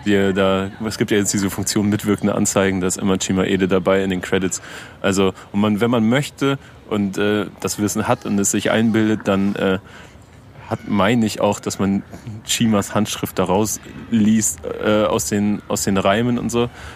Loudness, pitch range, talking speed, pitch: -19 LUFS, 95-110 Hz, 190 wpm, 105 Hz